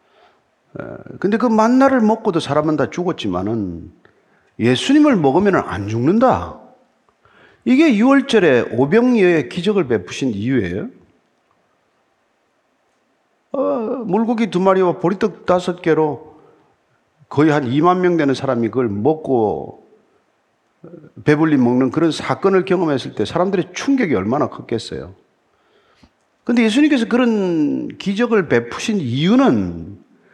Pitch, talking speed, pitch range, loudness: 180 Hz, 250 characters per minute, 150-235 Hz, -17 LUFS